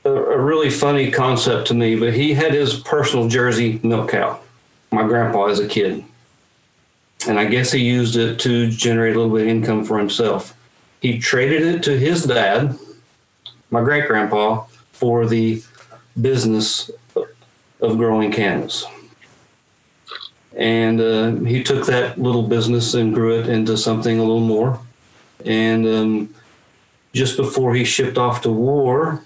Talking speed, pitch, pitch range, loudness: 150 wpm, 115 Hz, 110-130 Hz, -18 LUFS